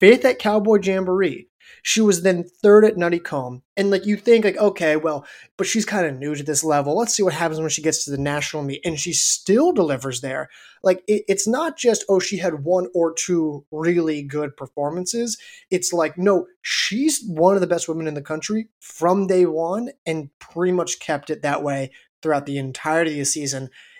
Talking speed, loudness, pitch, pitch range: 210 wpm, -20 LUFS, 175 Hz, 150-195 Hz